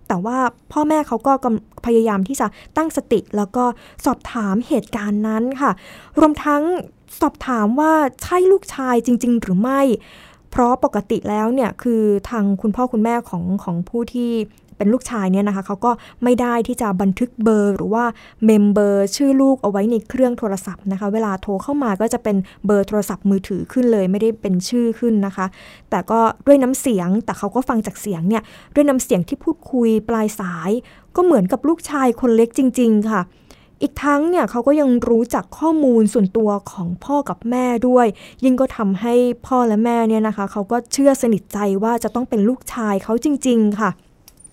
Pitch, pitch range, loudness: 230 Hz, 205-255 Hz, -18 LUFS